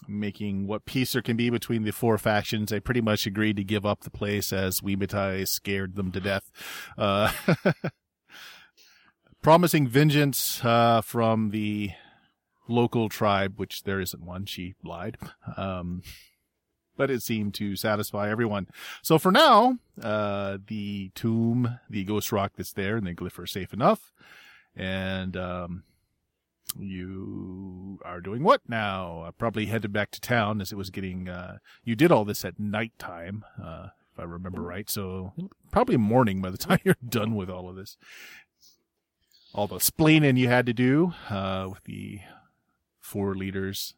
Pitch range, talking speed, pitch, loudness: 95-115 Hz, 160 wpm, 105 Hz, -26 LUFS